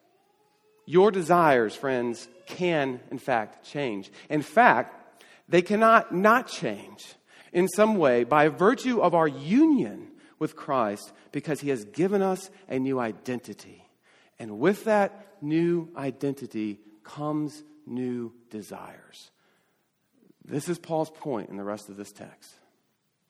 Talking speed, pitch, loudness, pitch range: 125 wpm, 155 Hz, -25 LUFS, 125-200 Hz